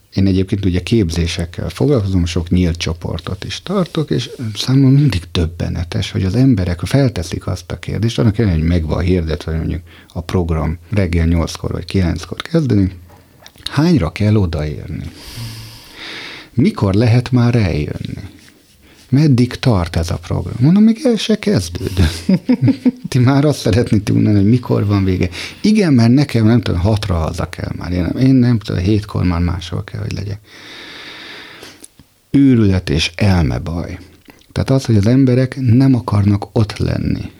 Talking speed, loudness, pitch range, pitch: 150 wpm, -15 LUFS, 90-125 Hz, 100 Hz